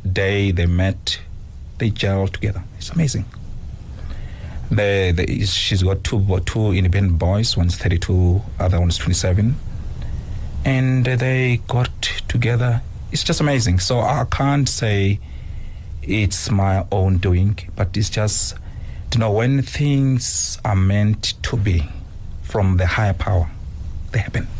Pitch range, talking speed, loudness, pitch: 90-115 Hz, 135 wpm, -19 LUFS, 100 Hz